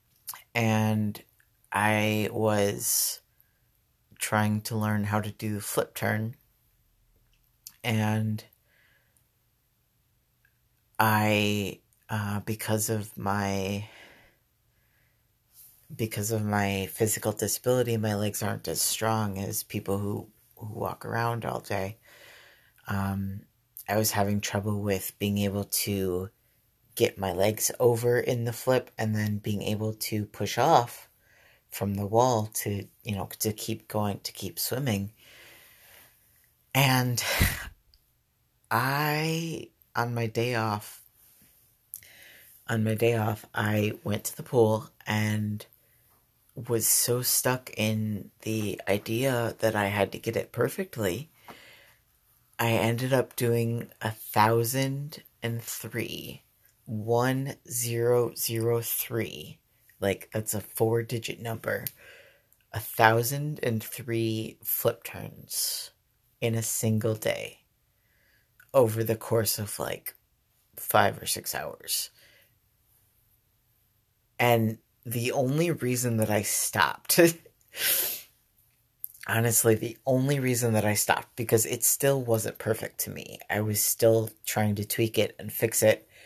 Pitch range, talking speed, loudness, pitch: 105-120 Hz, 115 wpm, -28 LUFS, 115 Hz